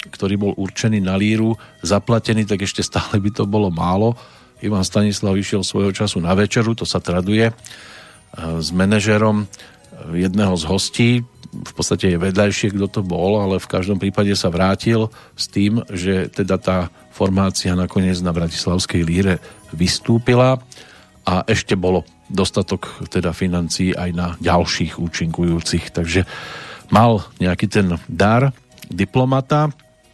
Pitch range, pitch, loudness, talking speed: 90-110 Hz, 100 Hz, -18 LUFS, 135 wpm